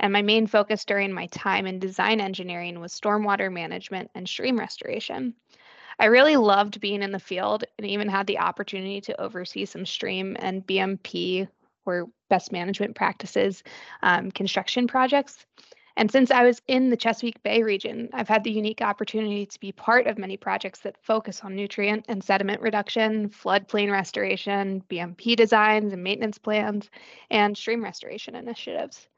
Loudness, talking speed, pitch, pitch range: -24 LUFS, 160 wpm, 205 Hz, 195-225 Hz